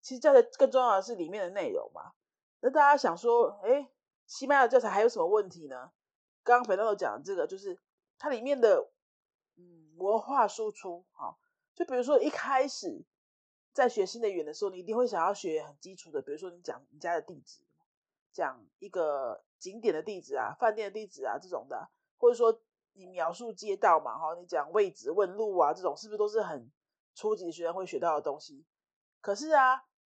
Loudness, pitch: -30 LUFS, 245 Hz